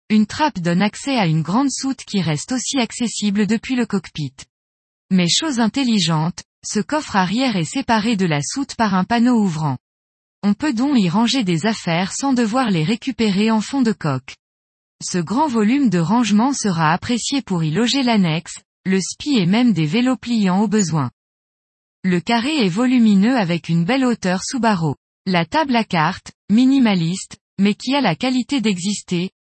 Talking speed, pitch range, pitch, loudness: 175 wpm, 175-245 Hz, 215 Hz, -18 LUFS